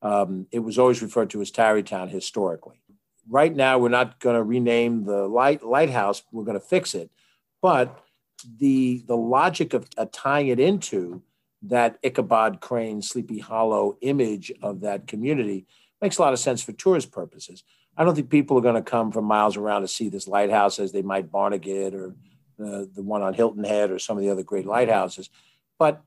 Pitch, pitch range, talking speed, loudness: 115 Hz, 100-130 Hz, 195 wpm, -23 LUFS